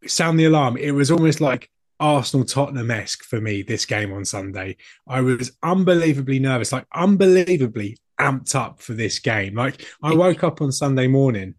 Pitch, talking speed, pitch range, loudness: 135 Hz, 175 wpm, 115-155 Hz, -20 LUFS